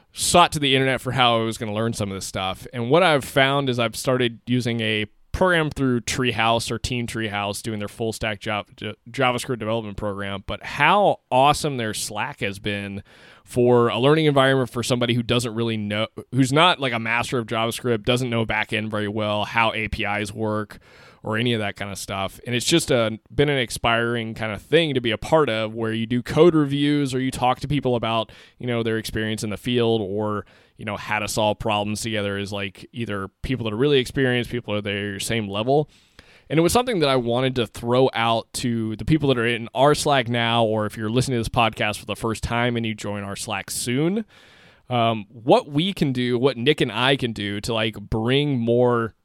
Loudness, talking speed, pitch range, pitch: -22 LUFS, 225 wpm, 105-130 Hz, 115 Hz